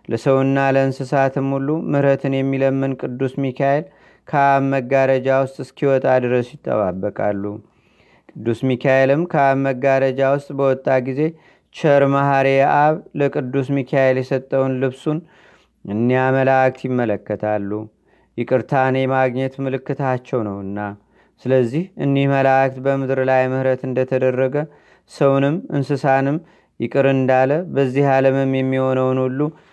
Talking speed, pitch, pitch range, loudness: 95 wpm, 135 Hz, 130-140 Hz, -18 LUFS